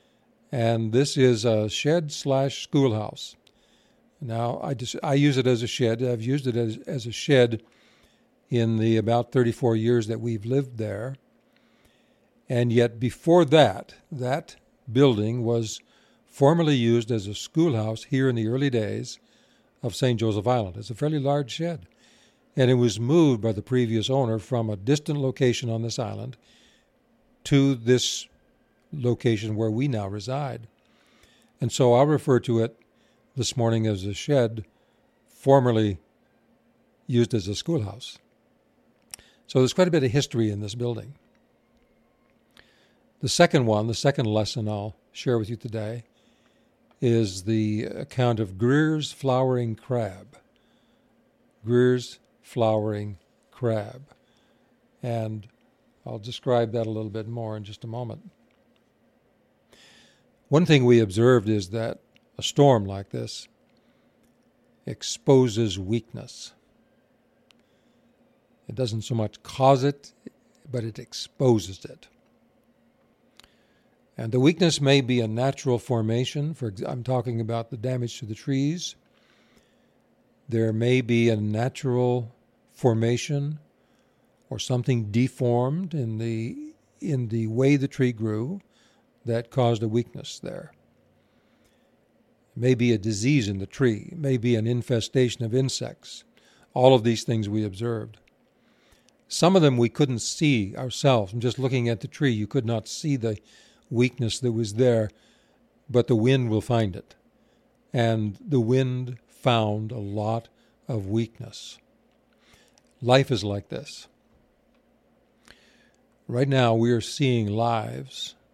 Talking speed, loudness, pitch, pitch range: 135 wpm, -24 LUFS, 120 Hz, 115-135 Hz